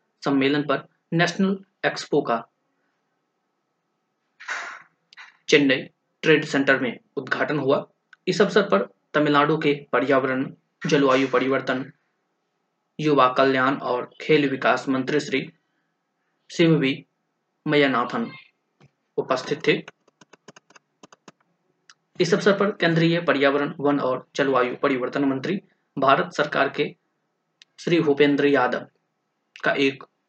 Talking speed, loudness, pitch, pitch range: 90 wpm, -22 LUFS, 145 Hz, 135-165 Hz